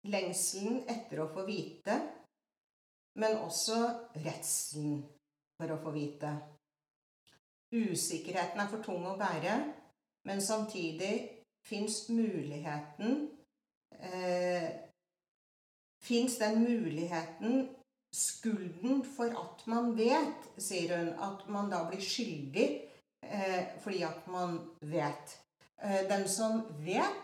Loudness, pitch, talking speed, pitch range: -36 LUFS, 190 Hz, 95 wpm, 165-225 Hz